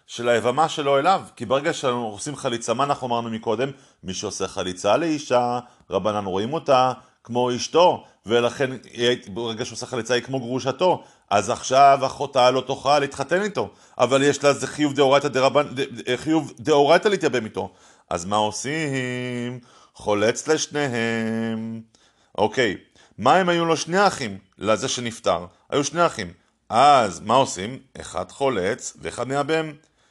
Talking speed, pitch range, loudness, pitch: 145 wpm, 115-145 Hz, -22 LUFS, 130 Hz